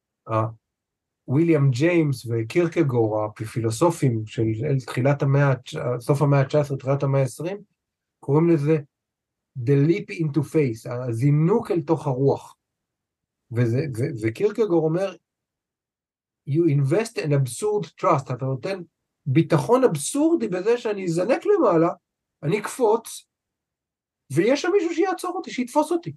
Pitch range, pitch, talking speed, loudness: 125-175 Hz, 150 Hz, 115 wpm, -22 LUFS